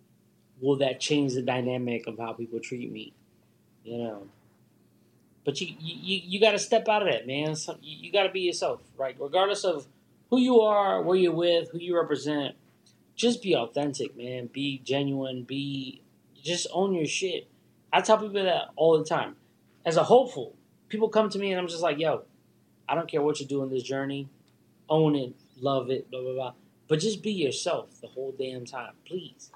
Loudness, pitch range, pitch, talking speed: -28 LUFS, 130-185 Hz, 150 Hz, 200 wpm